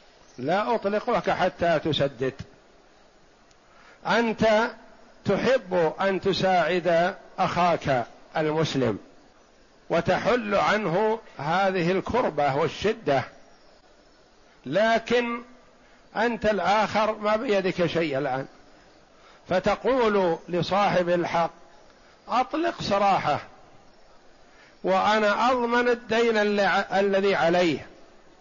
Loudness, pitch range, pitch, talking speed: -24 LUFS, 175-220 Hz, 195 Hz, 70 wpm